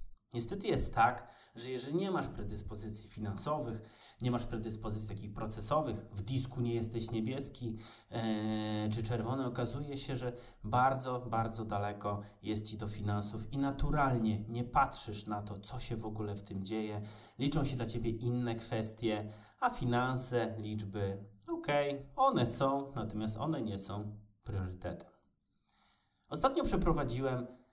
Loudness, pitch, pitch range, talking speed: -35 LUFS, 115 Hz, 105-125 Hz, 140 wpm